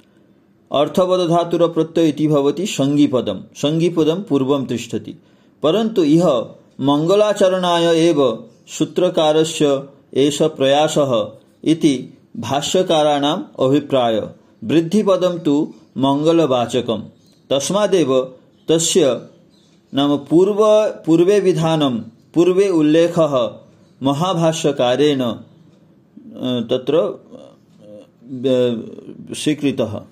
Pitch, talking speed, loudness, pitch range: 155 Hz, 70 wpm, -17 LUFS, 140-175 Hz